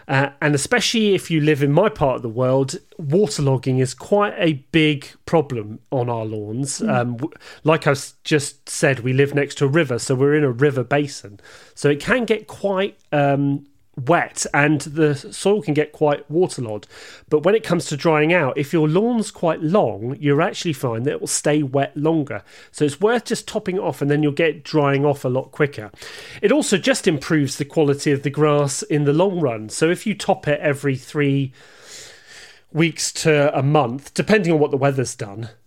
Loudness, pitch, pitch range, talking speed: -19 LUFS, 150 Hz, 140-170 Hz, 200 wpm